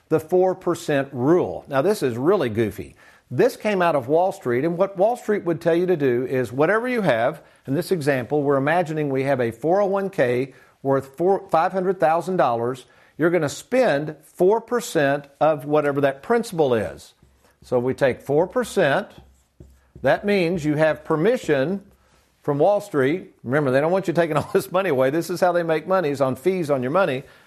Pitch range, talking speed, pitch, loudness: 140-190 Hz, 175 wpm, 160 Hz, -21 LUFS